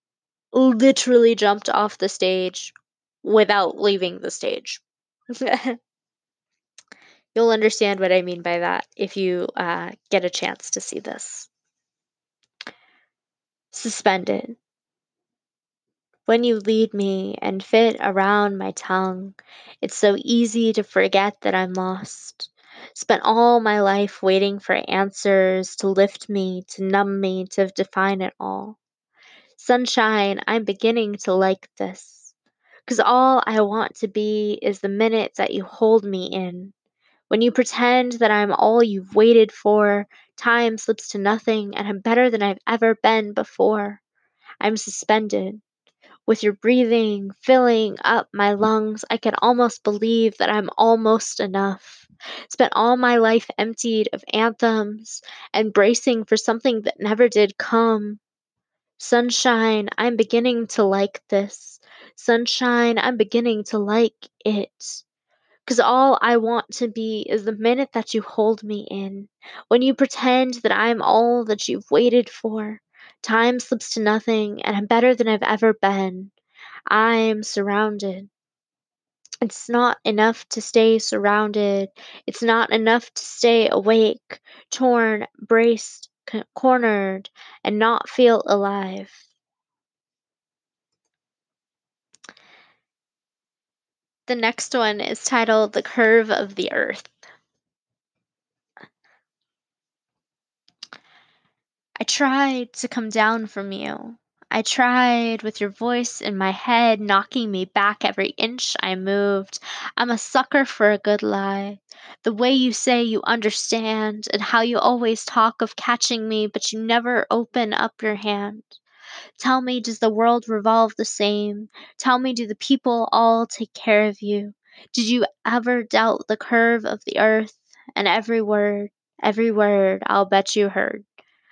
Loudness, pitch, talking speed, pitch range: -20 LUFS, 220 Hz, 135 wpm, 205-235 Hz